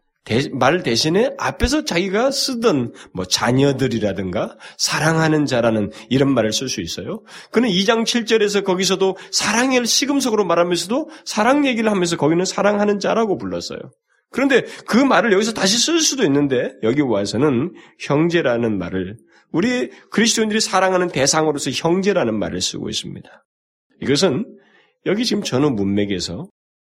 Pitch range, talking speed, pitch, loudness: 130-220 Hz, 340 characters per minute, 175 Hz, -18 LUFS